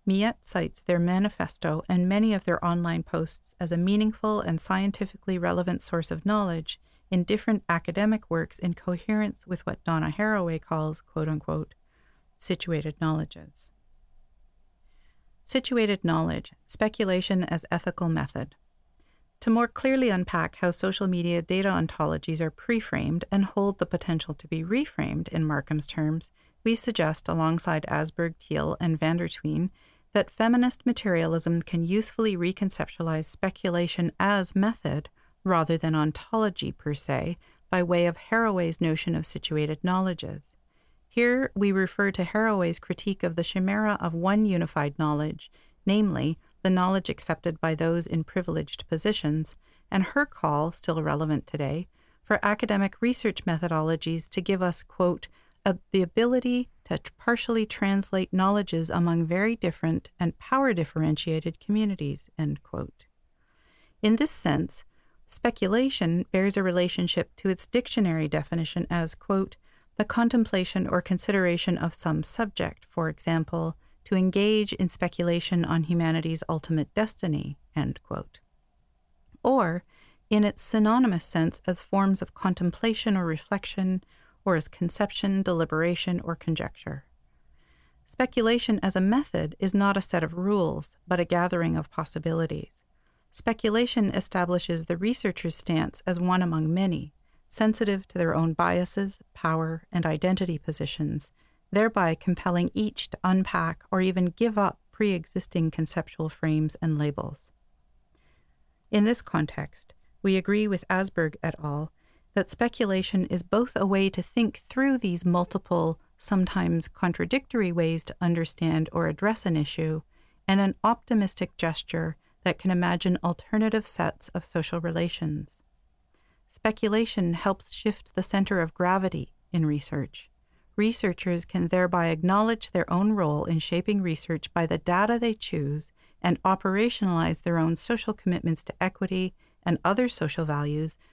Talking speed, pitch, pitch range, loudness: 135 wpm, 180 Hz, 165-200 Hz, -27 LUFS